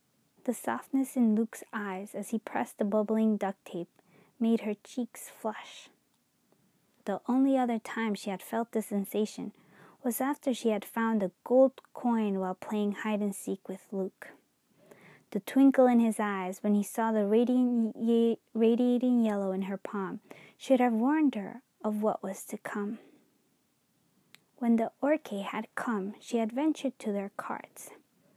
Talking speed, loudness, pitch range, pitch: 155 wpm, -30 LUFS, 205-245 Hz, 225 Hz